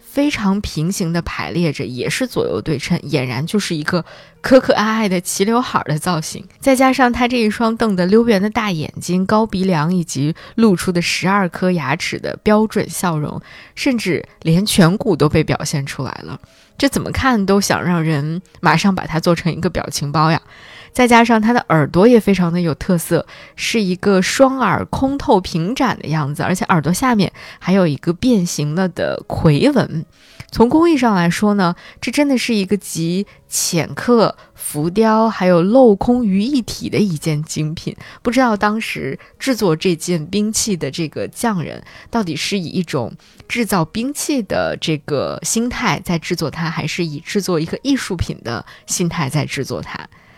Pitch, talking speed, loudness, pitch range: 185 Hz, 260 characters per minute, -17 LUFS, 165-225 Hz